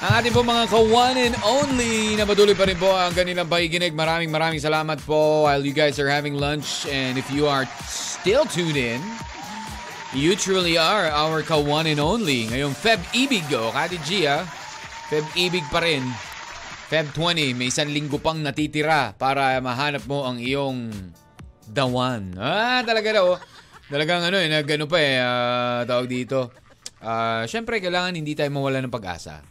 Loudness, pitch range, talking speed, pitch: -21 LUFS, 130-180 Hz, 170 wpm, 150 Hz